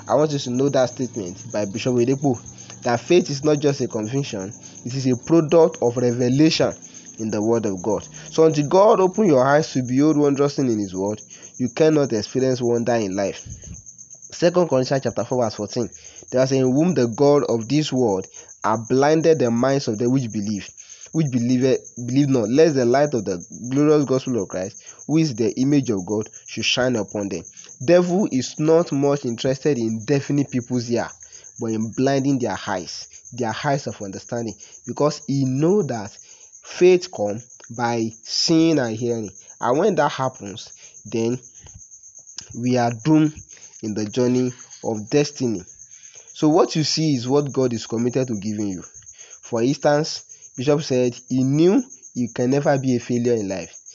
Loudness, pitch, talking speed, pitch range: -20 LUFS, 125 Hz, 180 wpm, 115-145 Hz